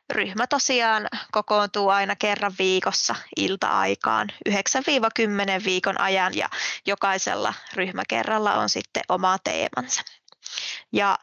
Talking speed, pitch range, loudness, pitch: 95 wpm, 190-215 Hz, -23 LUFS, 200 Hz